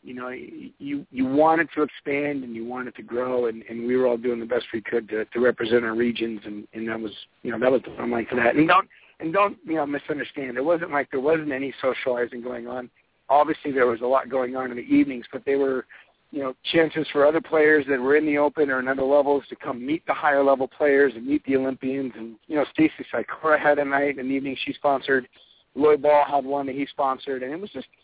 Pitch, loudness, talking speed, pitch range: 135 Hz, -23 LUFS, 255 wpm, 125-150 Hz